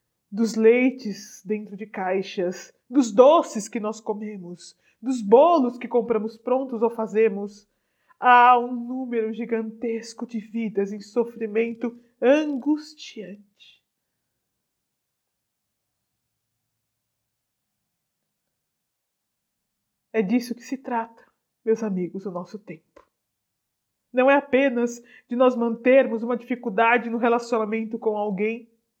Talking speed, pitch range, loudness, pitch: 100 wpm, 200-245 Hz, -22 LUFS, 225 Hz